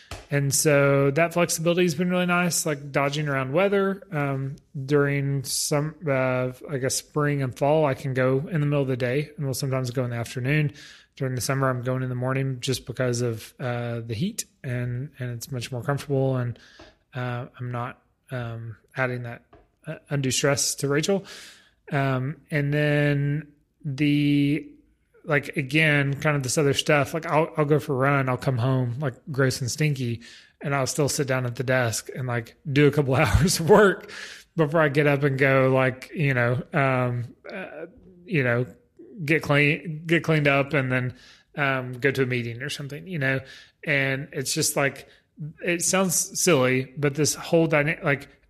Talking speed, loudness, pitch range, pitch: 185 wpm, -24 LUFS, 130-155 Hz, 140 Hz